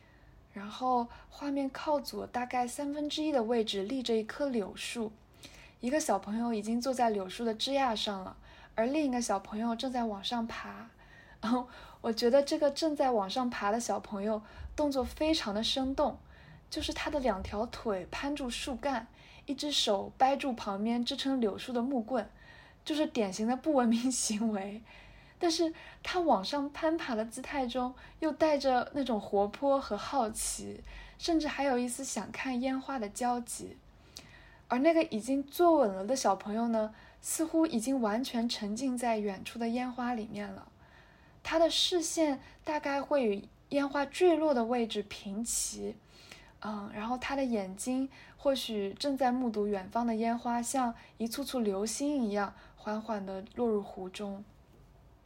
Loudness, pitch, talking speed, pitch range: -33 LUFS, 245 Hz, 240 characters per minute, 215-280 Hz